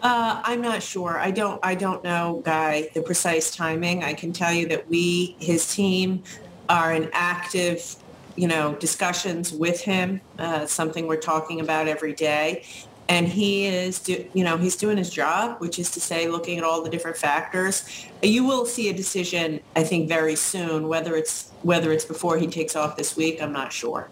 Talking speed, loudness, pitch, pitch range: 195 wpm, -24 LUFS, 170 Hz, 160-185 Hz